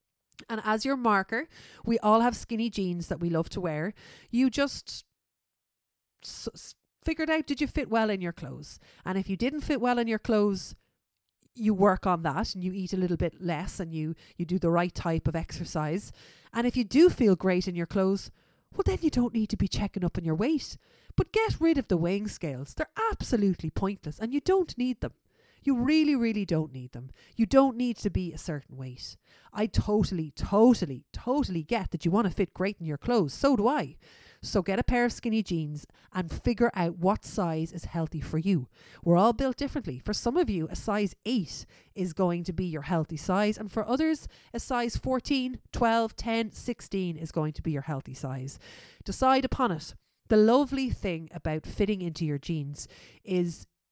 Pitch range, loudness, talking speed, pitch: 165-240 Hz, -29 LUFS, 205 wpm, 195 Hz